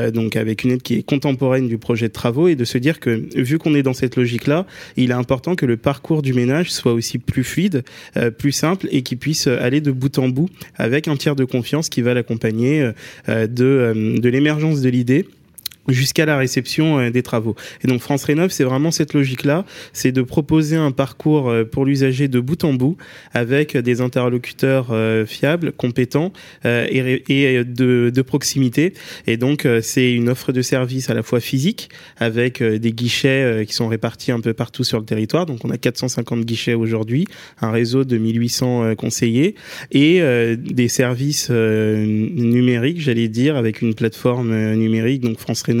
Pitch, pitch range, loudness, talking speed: 125 Hz, 115-145 Hz, -18 LUFS, 180 wpm